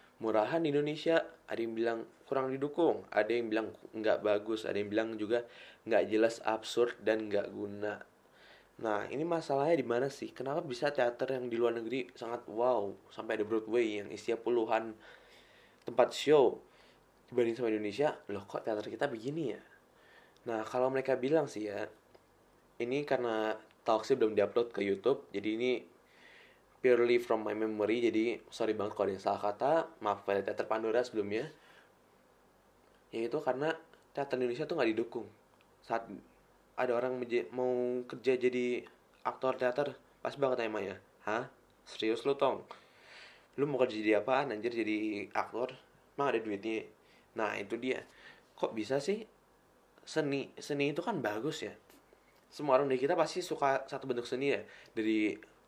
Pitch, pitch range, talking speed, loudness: 120 Hz, 110-135 Hz, 155 wpm, -34 LUFS